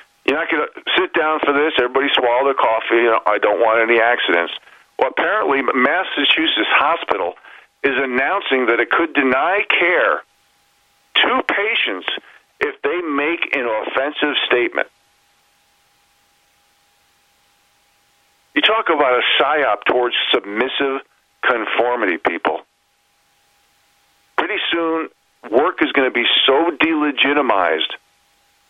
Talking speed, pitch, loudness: 115 wpm, 160 Hz, -17 LUFS